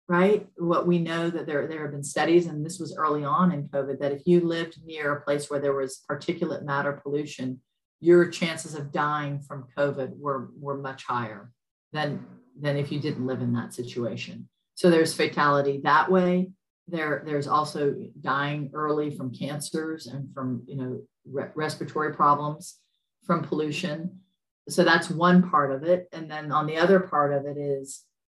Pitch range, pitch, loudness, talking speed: 140-165 Hz, 150 Hz, -26 LUFS, 180 wpm